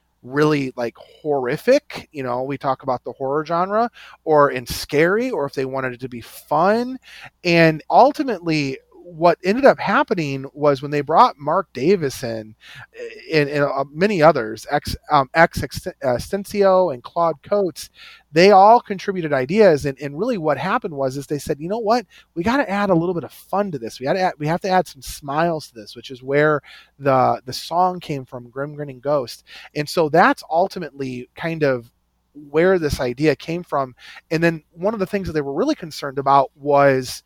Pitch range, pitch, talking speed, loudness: 135-190 Hz, 150 Hz, 190 wpm, -19 LUFS